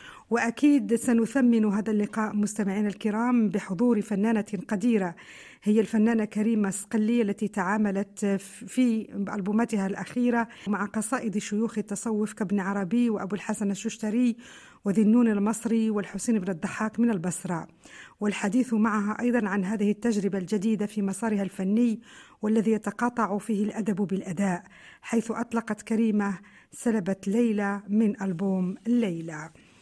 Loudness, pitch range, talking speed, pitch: -27 LUFS, 200-230 Hz, 115 wpm, 215 Hz